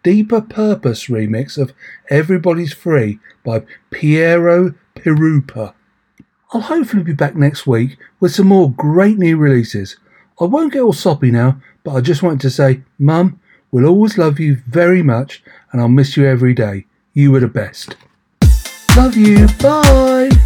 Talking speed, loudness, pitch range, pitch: 155 wpm, -13 LUFS, 130-180 Hz, 150 Hz